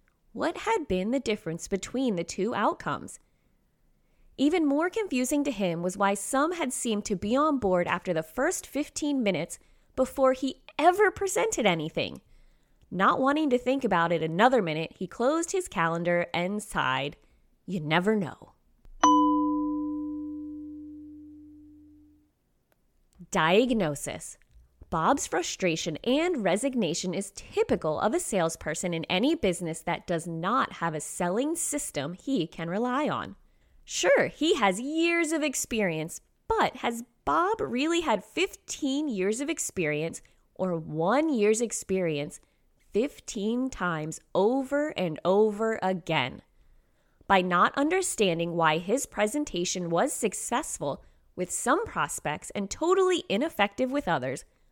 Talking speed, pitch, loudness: 125 wpm, 225 Hz, -28 LUFS